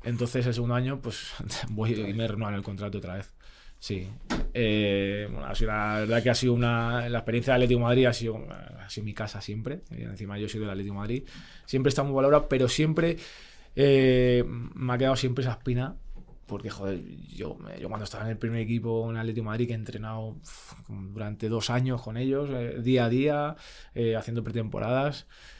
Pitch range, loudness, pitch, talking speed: 110-130 Hz, -28 LUFS, 115 Hz, 205 wpm